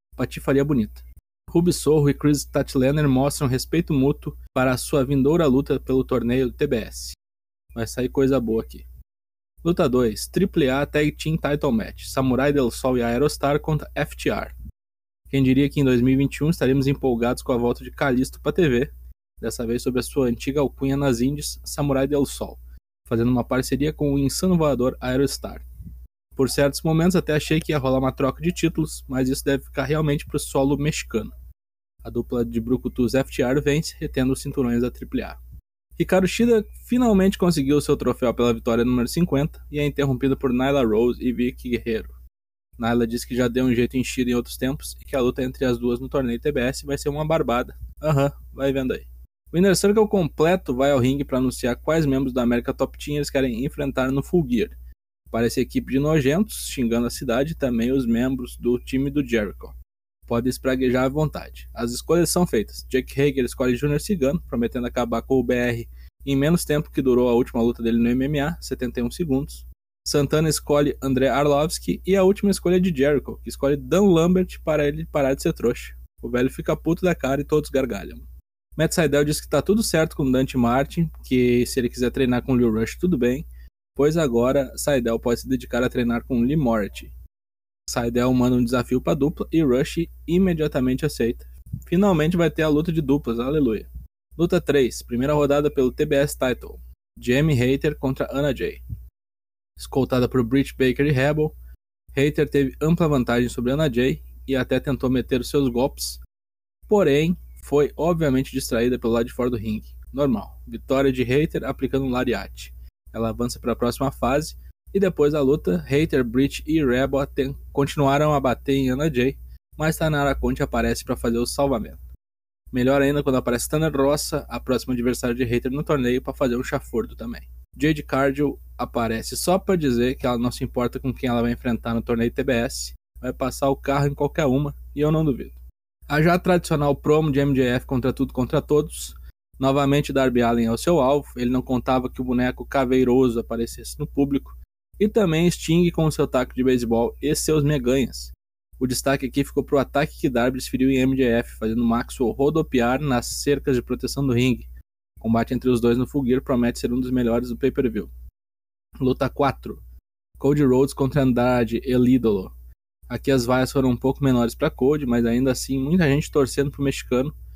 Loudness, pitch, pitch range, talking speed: -22 LUFS, 130 Hz, 120-145 Hz, 190 wpm